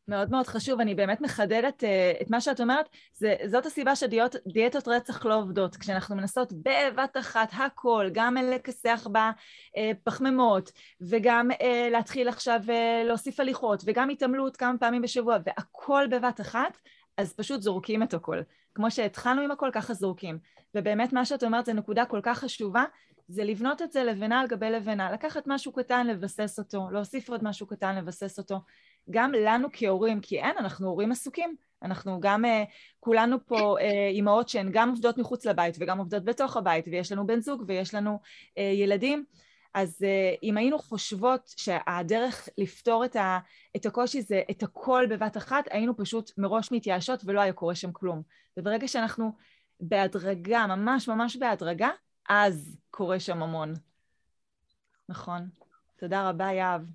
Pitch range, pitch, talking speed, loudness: 200-245 Hz, 225 Hz, 160 wpm, -28 LUFS